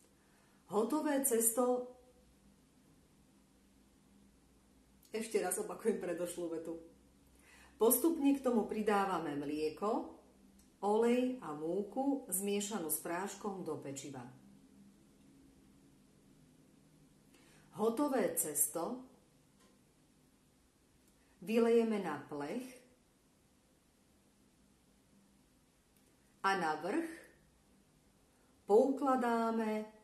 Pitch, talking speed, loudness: 175 Hz, 60 wpm, -35 LUFS